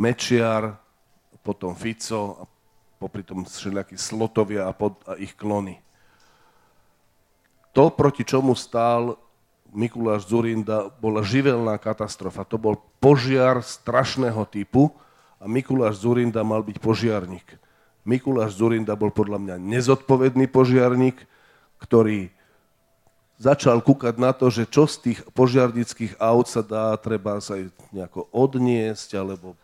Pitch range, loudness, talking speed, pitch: 105-125 Hz, -22 LUFS, 115 wpm, 110 Hz